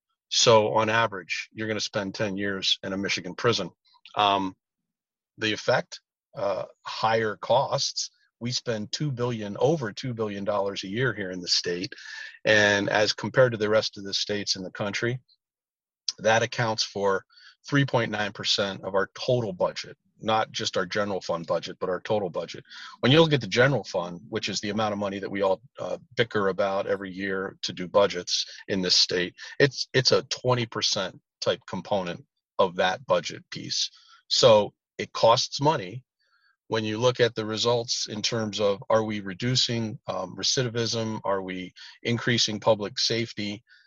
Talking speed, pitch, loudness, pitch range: 170 wpm, 110 Hz, -26 LUFS, 100-120 Hz